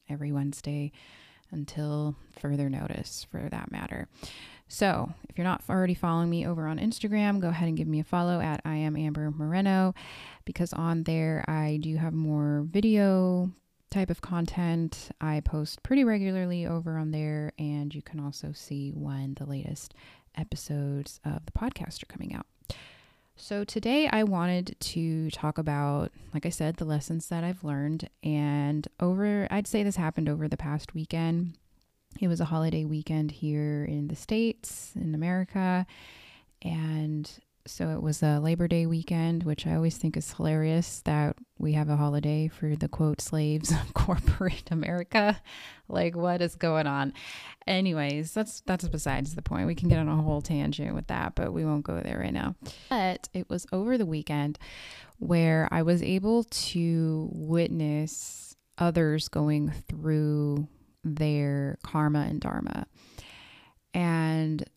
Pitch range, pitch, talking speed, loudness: 150-175 Hz, 155 Hz, 160 wpm, -29 LUFS